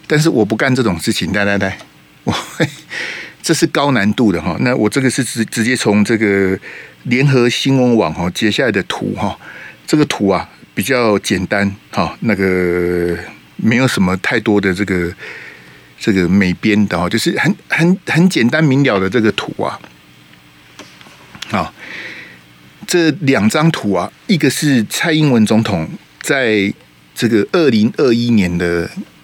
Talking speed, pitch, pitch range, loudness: 220 characters per minute, 110 Hz, 95-135 Hz, -14 LUFS